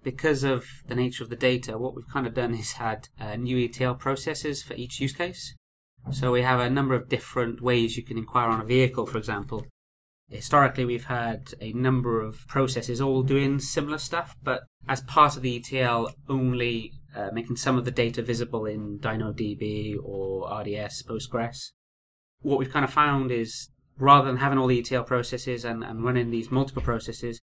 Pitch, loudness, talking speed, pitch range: 125 Hz, -26 LUFS, 190 wpm, 115-135 Hz